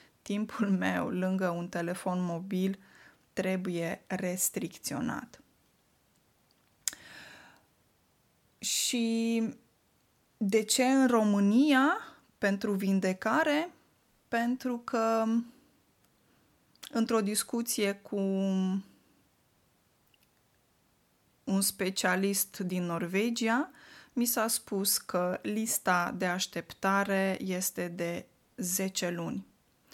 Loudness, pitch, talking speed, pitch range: -30 LUFS, 200 Hz, 70 wpm, 185-230 Hz